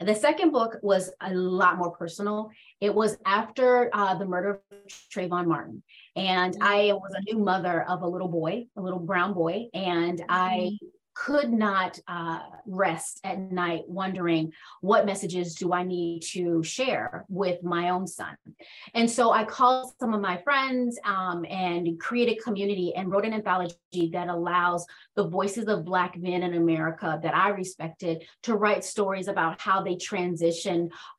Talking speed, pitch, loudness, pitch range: 165 wpm, 185 Hz, -27 LUFS, 175-210 Hz